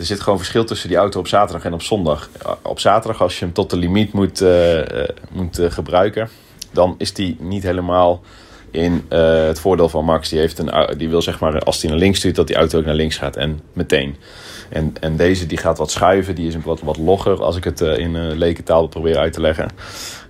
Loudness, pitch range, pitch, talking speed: -17 LUFS, 80-95 Hz, 85 Hz, 240 wpm